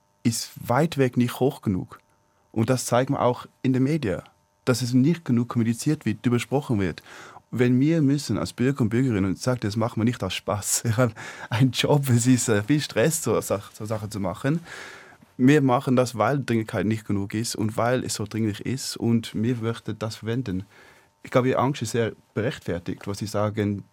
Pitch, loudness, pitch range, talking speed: 120 Hz, -24 LUFS, 105-130 Hz, 205 wpm